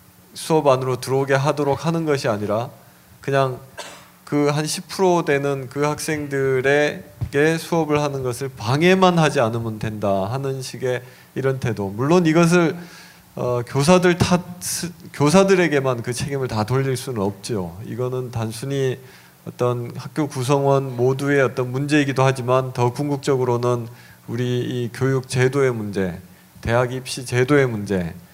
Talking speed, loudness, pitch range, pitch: 285 characters per minute, -20 LUFS, 125-150 Hz, 135 Hz